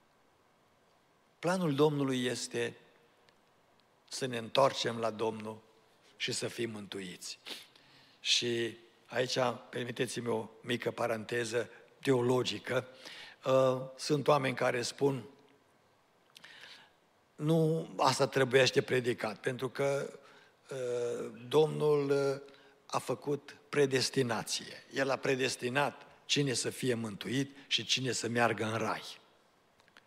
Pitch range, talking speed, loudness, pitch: 115-140 Hz, 90 wpm, -33 LUFS, 125 Hz